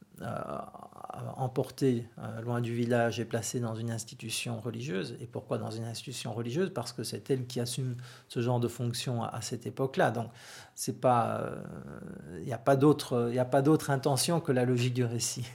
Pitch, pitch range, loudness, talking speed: 120 Hz, 115-135 Hz, -32 LUFS, 180 wpm